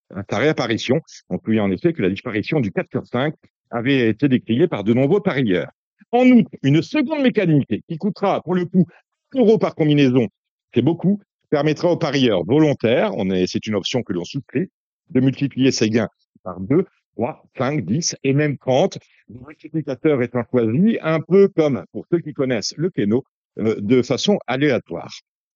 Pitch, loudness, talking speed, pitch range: 140 Hz, -19 LUFS, 180 wpm, 120-175 Hz